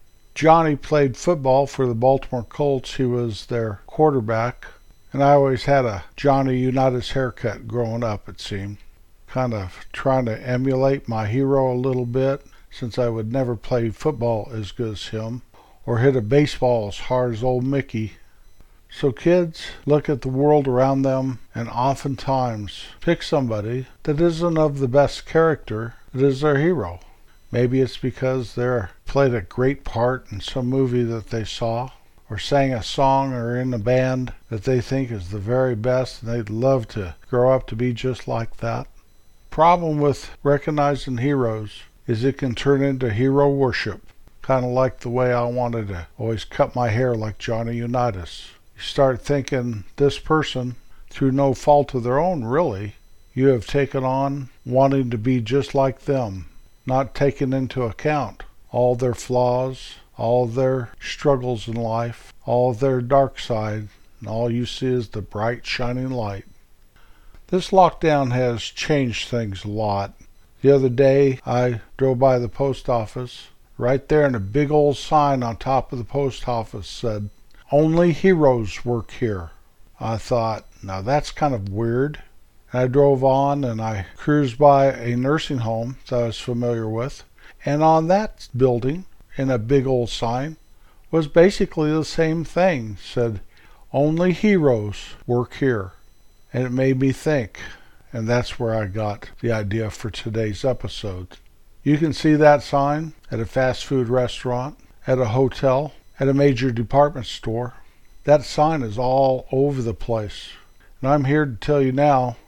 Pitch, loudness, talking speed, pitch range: 125 Hz, -21 LUFS, 165 wpm, 115-140 Hz